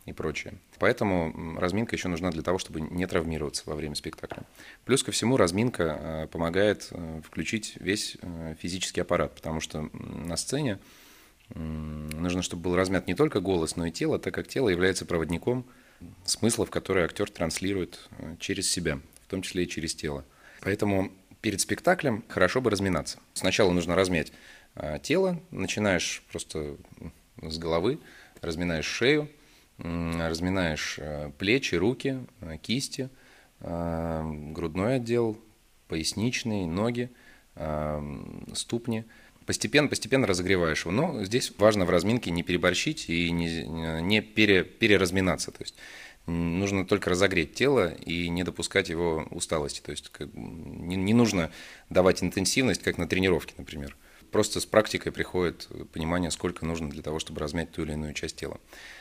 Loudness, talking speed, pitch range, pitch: -28 LUFS, 135 wpm, 80-105 Hz, 90 Hz